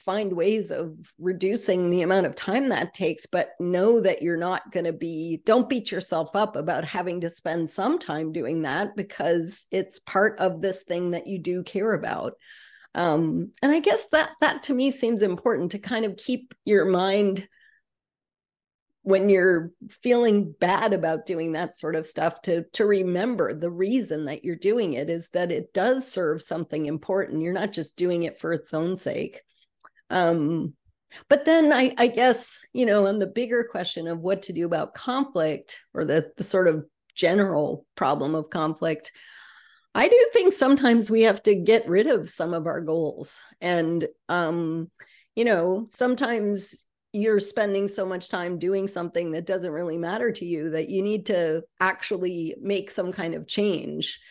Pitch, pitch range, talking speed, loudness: 185 Hz, 165-215 Hz, 180 wpm, -24 LUFS